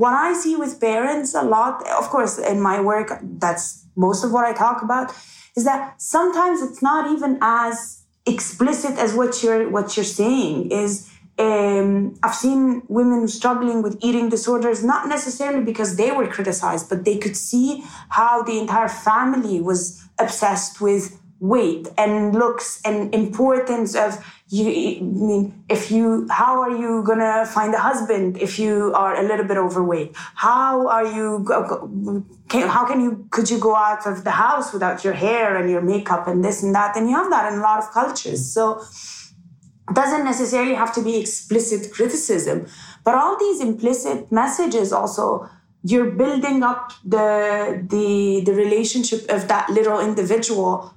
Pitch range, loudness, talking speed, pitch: 205-245 Hz, -20 LUFS, 170 wpm, 220 Hz